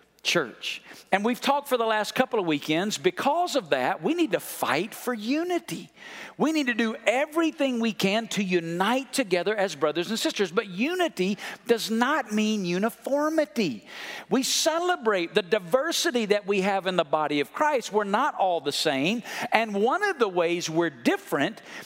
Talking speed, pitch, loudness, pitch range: 175 wpm, 225 Hz, -26 LUFS, 190-280 Hz